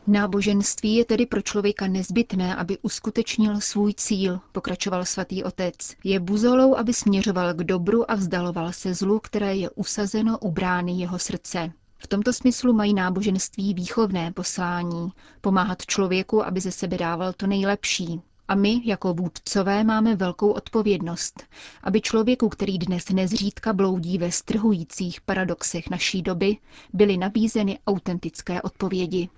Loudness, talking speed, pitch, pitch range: -24 LUFS, 135 wpm, 195 Hz, 180-210 Hz